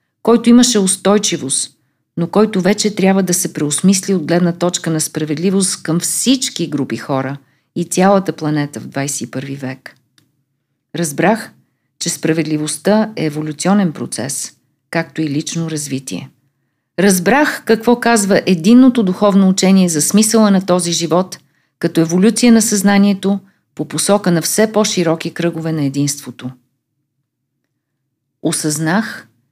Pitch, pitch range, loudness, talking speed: 170 Hz, 145-195 Hz, -14 LUFS, 120 wpm